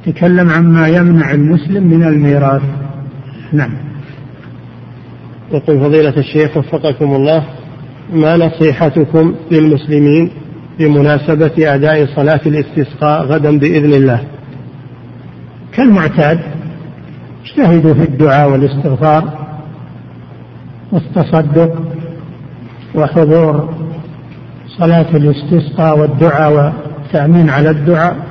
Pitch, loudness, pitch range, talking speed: 155 Hz, -10 LUFS, 145-160 Hz, 75 wpm